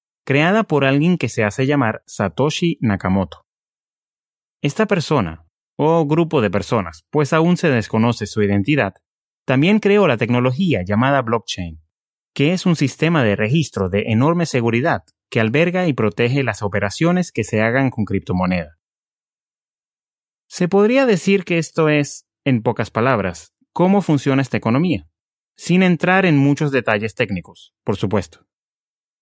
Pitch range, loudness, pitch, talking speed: 110-165 Hz, -18 LUFS, 135 Hz, 140 wpm